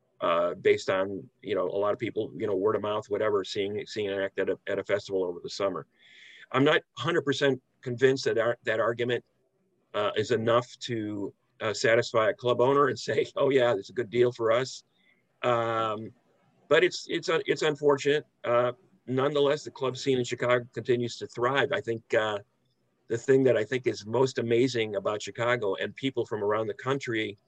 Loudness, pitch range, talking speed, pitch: -28 LUFS, 115-135 Hz, 195 wpm, 125 Hz